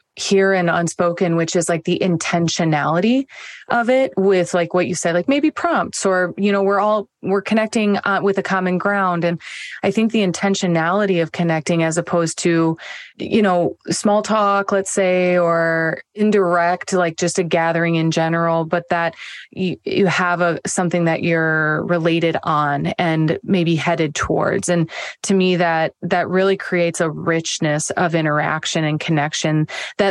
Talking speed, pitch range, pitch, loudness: 165 wpm, 165-195 Hz, 175 Hz, -18 LUFS